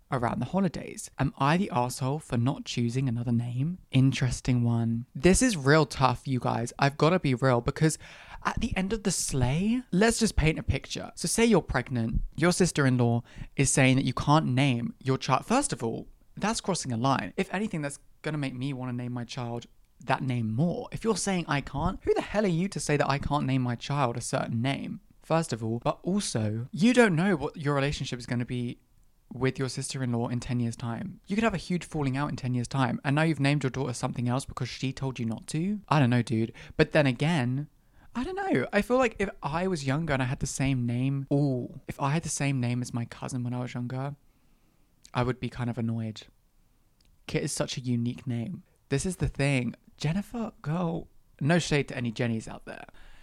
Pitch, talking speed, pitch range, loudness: 135 Hz, 225 wpm, 125-165 Hz, -28 LUFS